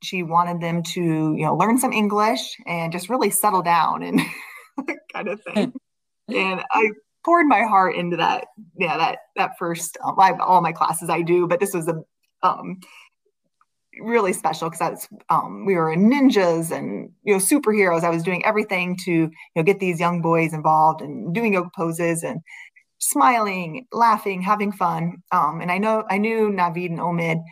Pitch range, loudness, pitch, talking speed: 170-215 Hz, -21 LUFS, 180 Hz, 180 wpm